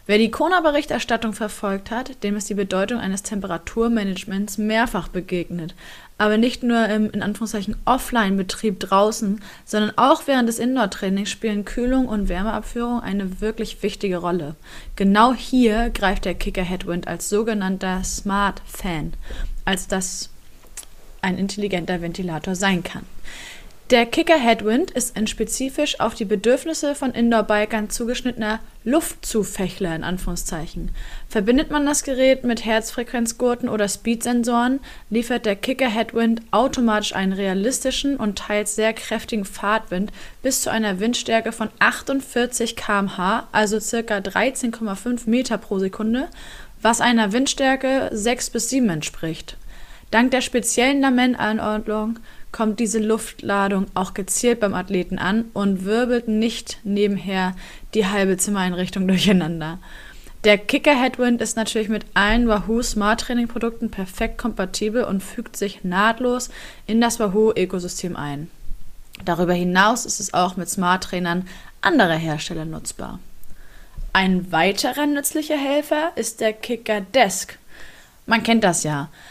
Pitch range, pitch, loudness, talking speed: 195-235 Hz, 215 Hz, -21 LUFS, 125 wpm